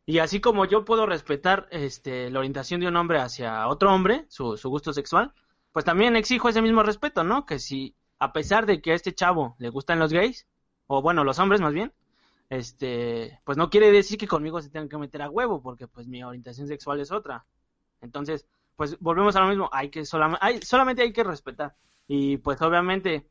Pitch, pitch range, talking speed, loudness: 155 Hz, 135-195 Hz, 210 wpm, -24 LUFS